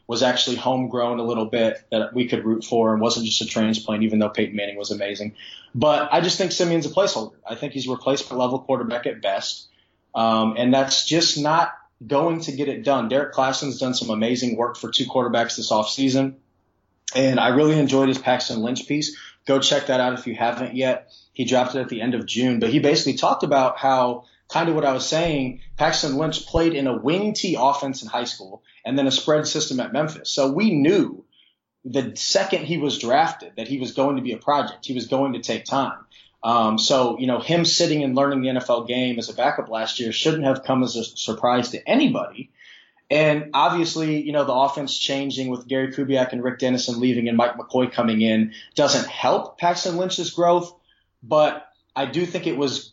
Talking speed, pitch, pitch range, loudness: 215 wpm, 130 Hz, 120-145 Hz, -21 LUFS